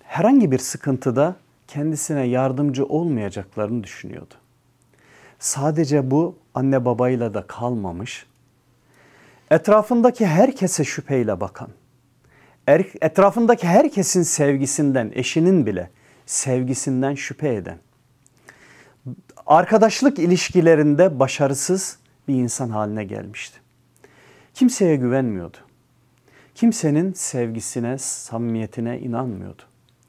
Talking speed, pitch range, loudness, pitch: 75 wpm, 125-160 Hz, -20 LUFS, 135 Hz